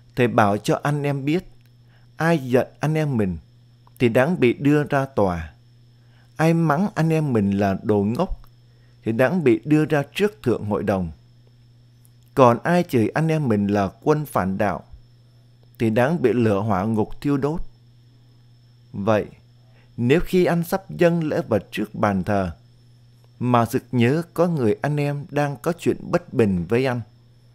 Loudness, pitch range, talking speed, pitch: -21 LUFS, 115-145 Hz, 170 wpm, 120 Hz